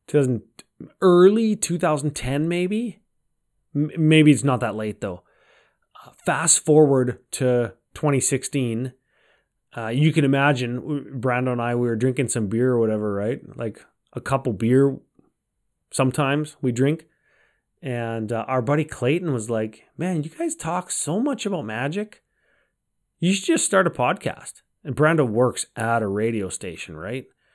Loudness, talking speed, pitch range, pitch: -22 LUFS, 145 wpm, 120-155 Hz, 135 Hz